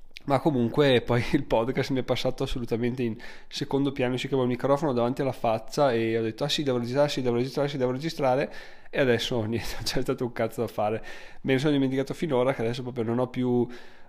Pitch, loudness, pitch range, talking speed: 125 Hz, -27 LUFS, 120-135 Hz, 215 wpm